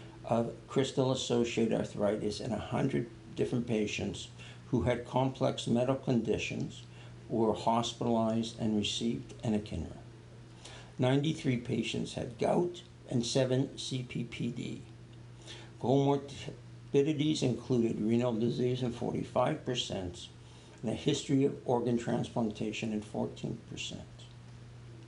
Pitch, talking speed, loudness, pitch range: 120 Hz, 95 wpm, -33 LUFS, 115-130 Hz